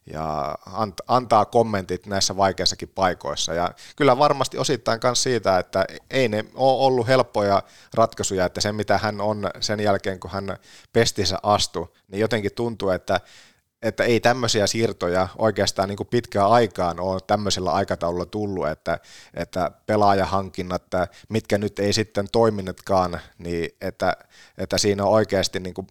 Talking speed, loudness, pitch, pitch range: 145 wpm, -22 LUFS, 100 Hz, 95-110 Hz